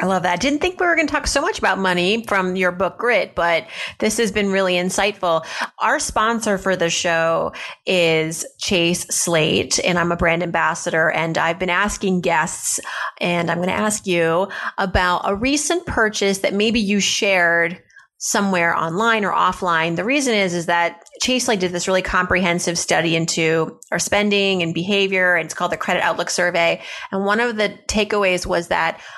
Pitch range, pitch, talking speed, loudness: 170-205 Hz, 185 Hz, 190 wpm, -18 LUFS